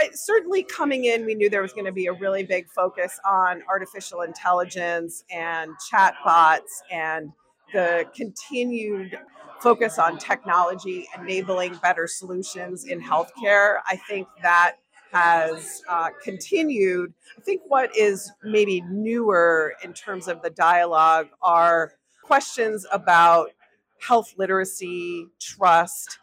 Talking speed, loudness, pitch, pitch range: 120 wpm, -22 LUFS, 185 Hz, 175-210 Hz